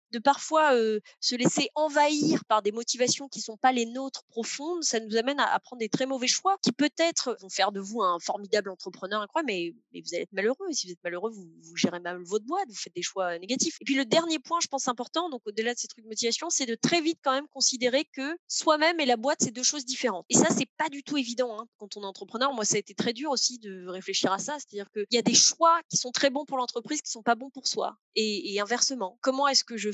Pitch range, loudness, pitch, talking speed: 215-290 Hz, -27 LUFS, 250 Hz, 280 wpm